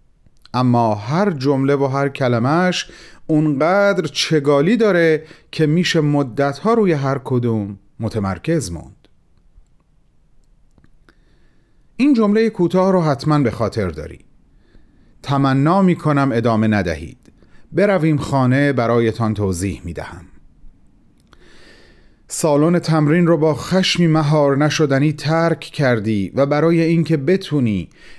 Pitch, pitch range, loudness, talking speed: 145 Hz, 115-165 Hz, -17 LUFS, 105 wpm